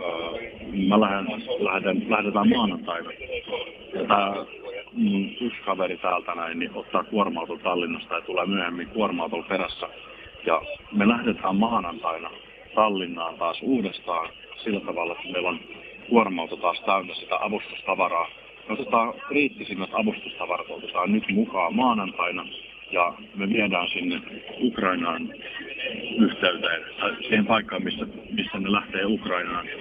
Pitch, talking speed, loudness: 110 Hz, 115 wpm, -26 LUFS